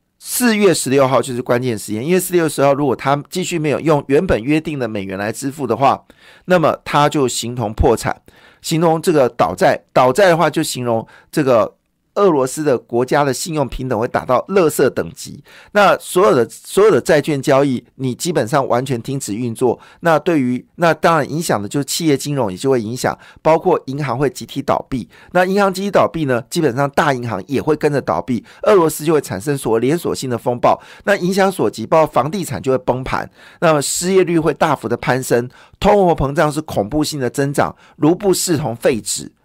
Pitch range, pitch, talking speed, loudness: 125-165 Hz, 140 Hz, 310 characters per minute, -16 LUFS